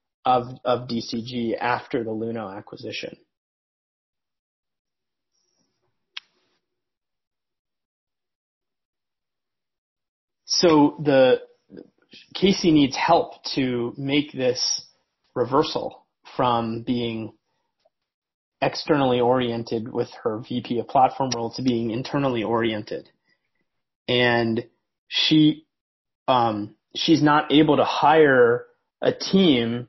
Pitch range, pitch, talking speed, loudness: 115-145 Hz, 125 Hz, 80 wpm, -22 LUFS